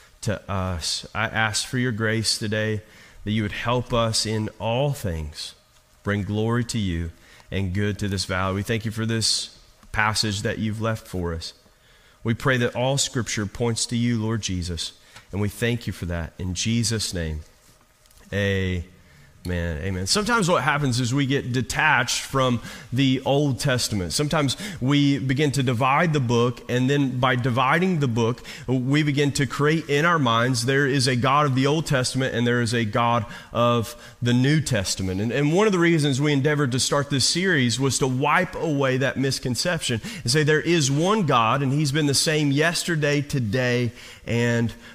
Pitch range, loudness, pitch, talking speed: 105-140 Hz, -23 LUFS, 120 Hz, 185 wpm